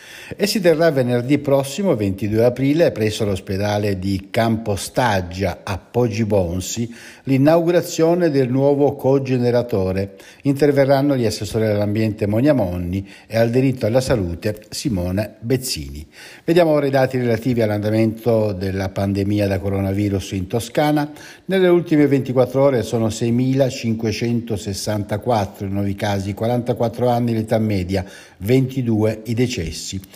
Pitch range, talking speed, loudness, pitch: 100-135 Hz, 110 wpm, -19 LUFS, 115 Hz